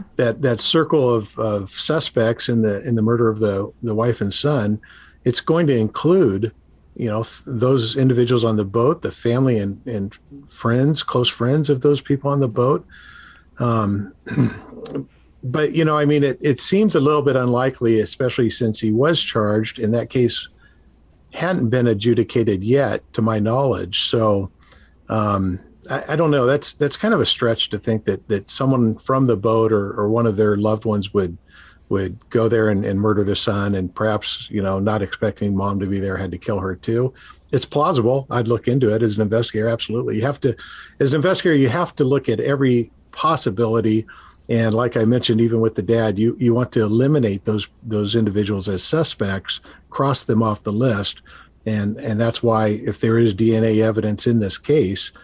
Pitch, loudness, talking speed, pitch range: 115 Hz, -19 LUFS, 195 wpm, 105-125 Hz